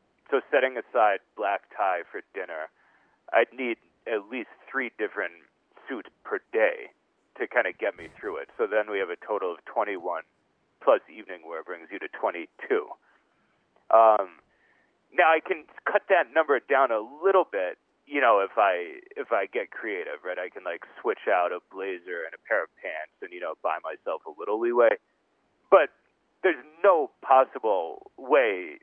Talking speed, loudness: 175 wpm, -26 LUFS